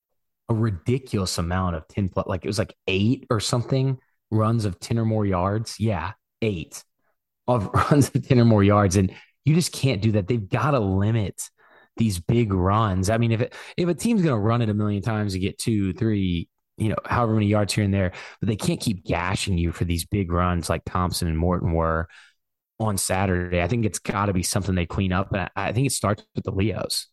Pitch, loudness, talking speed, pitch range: 105 Hz, -23 LUFS, 225 wpm, 95-115 Hz